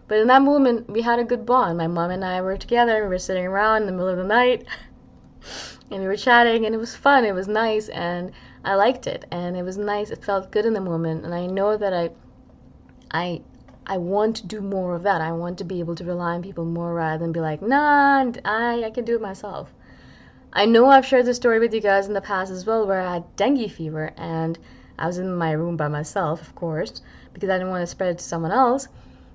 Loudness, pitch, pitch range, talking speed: -21 LUFS, 195 Hz, 175-225 Hz, 255 wpm